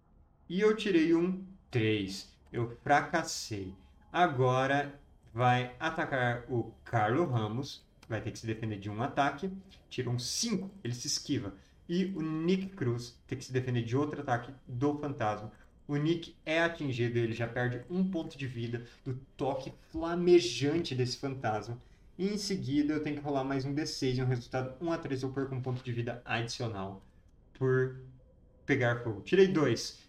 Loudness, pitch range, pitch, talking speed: -33 LUFS, 120-160 Hz, 130 Hz, 165 wpm